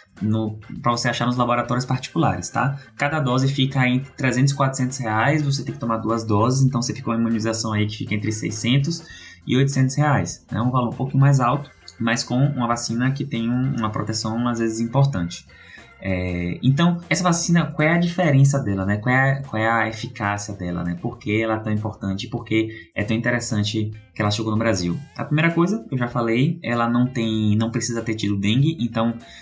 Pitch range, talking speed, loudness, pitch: 110-135 Hz, 215 wpm, -22 LUFS, 120 Hz